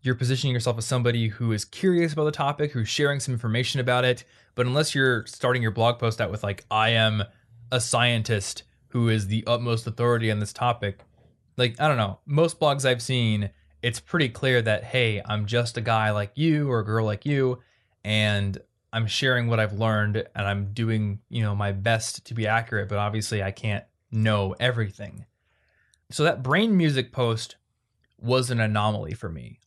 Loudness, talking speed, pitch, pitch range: -25 LUFS, 190 wpm, 115 Hz, 105-125 Hz